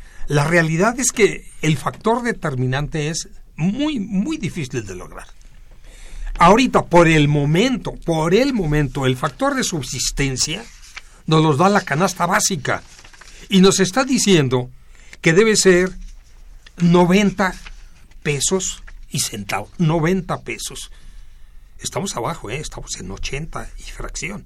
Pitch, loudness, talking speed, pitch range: 165 Hz, -18 LUFS, 125 wpm, 140-195 Hz